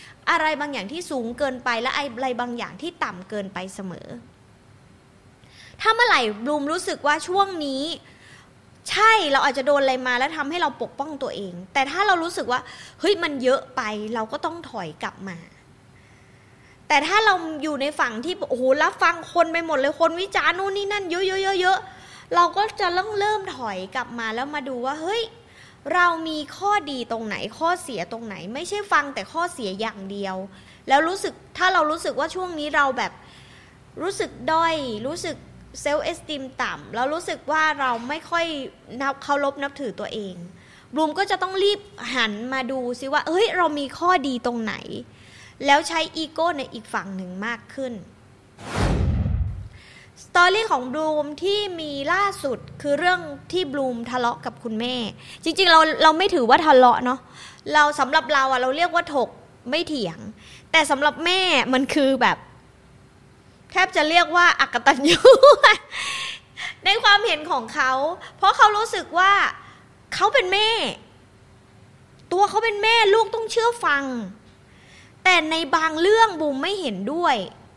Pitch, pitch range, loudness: 295 Hz, 250-355 Hz, -21 LUFS